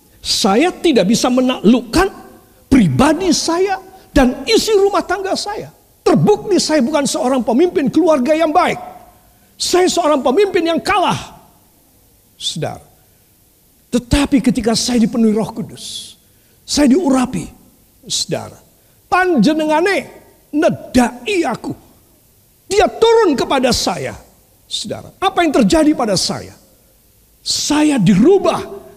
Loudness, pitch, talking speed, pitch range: -14 LUFS, 310 Hz, 100 wpm, 255-360 Hz